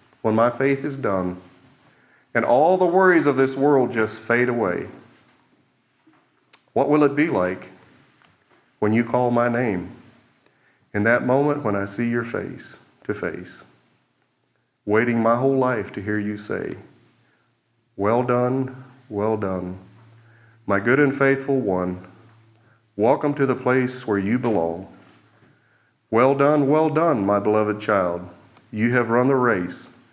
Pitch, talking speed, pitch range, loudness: 120 Hz, 140 wpm, 105-135 Hz, -21 LUFS